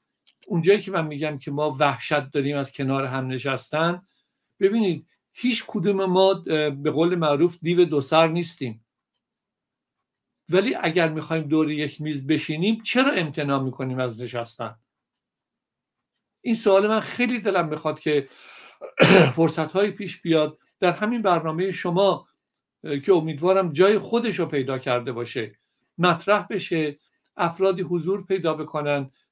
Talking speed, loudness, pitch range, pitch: 130 wpm, -23 LUFS, 145-190 Hz, 165 Hz